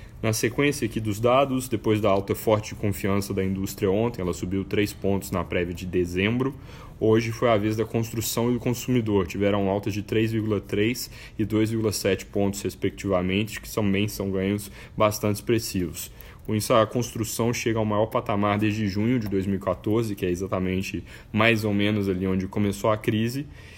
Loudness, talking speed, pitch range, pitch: -25 LUFS, 175 wpm, 100-115 Hz, 105 Hz